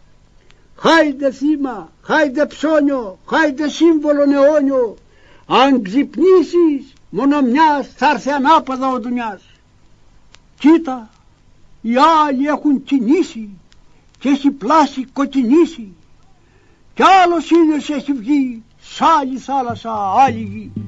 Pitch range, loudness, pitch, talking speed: 255-305 Hz, -15 LUFS, 280 Hz, 100 wpm